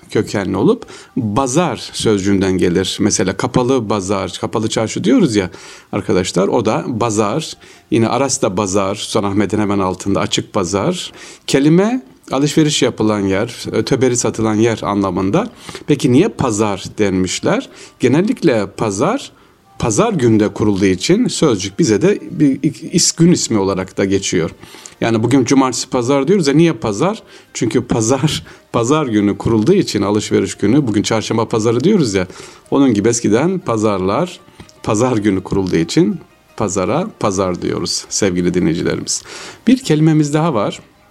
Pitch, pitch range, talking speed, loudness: 115 Hz, 100-150 Hz, 135 wpm, -15 LUFS